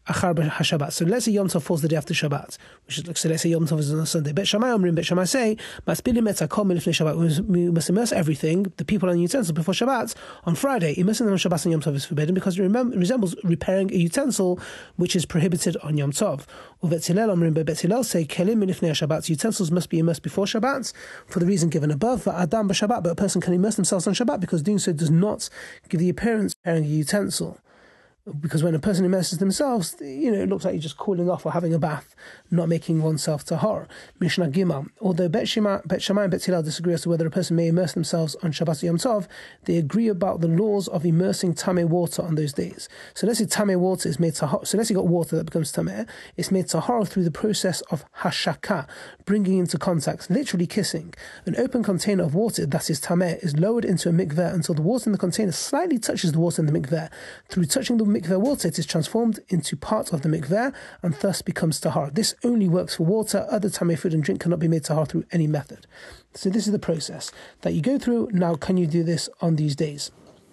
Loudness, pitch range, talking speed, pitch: -23 LUFS, 165-200 Hz, 225 wpm, 180 Hz